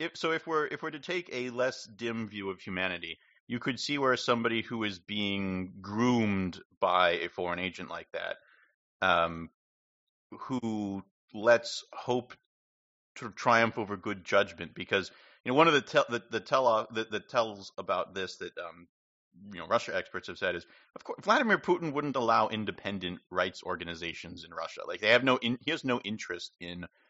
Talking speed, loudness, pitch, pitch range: 185 wpm, -31 LUFS, 110 Hz, 95-125 Hz